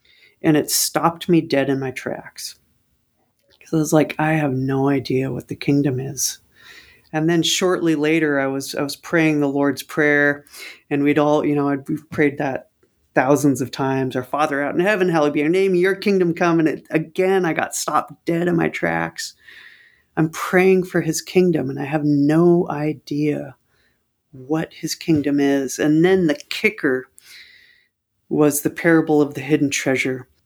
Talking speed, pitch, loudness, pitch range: 180 wpm, 150 Hz, -19 LUFS, 140-165 Hz